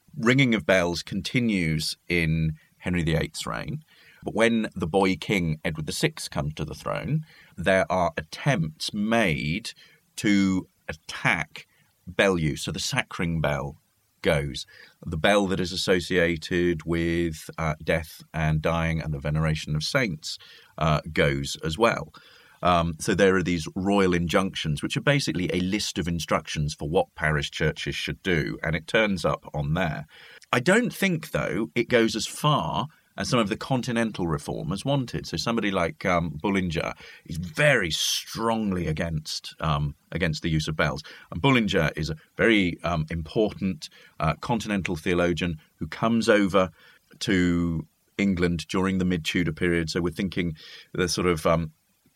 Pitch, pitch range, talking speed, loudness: 90 Hz, 80-105 Hz, 155 wpm, -25 LUFS